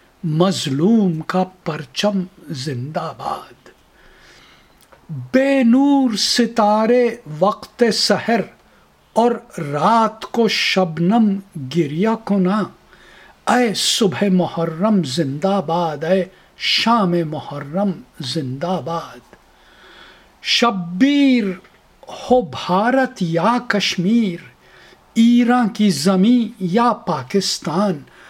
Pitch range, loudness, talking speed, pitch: 170-230 Hz, -18 LUFS, 75 wpm, 195 Hz